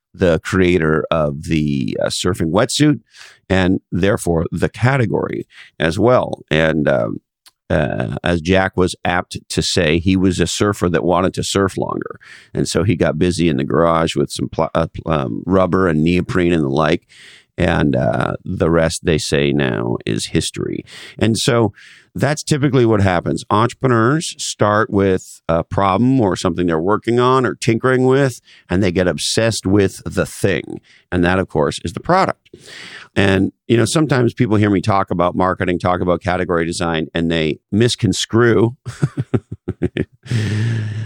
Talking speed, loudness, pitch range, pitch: 160 wpm, -17 LUFS, 85-115 Hz, 95 Hz